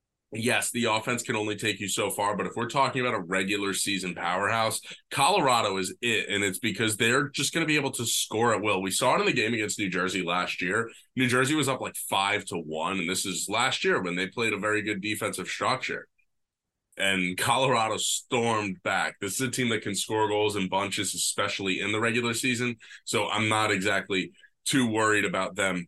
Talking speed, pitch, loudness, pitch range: 215 wpm, 105 Hz, -26 LUFS, 95-120 Hz